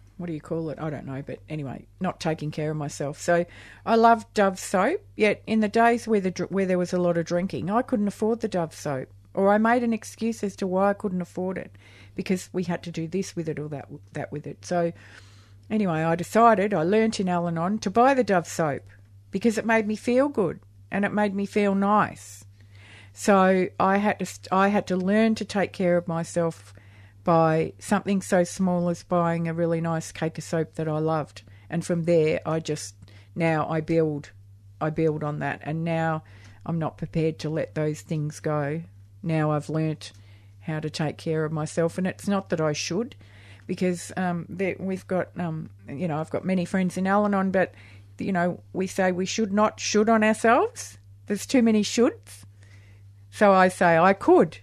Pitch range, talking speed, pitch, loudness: 150-195 Hz, 205 wpm, 170 Hz, -25 LUFS